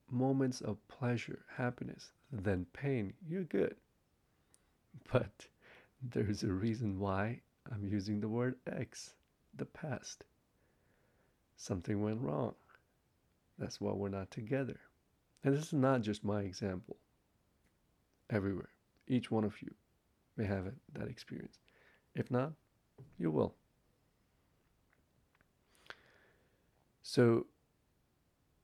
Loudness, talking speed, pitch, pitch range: -38 LUFS, 105 wpm, 110 Hz, 100-130 Hz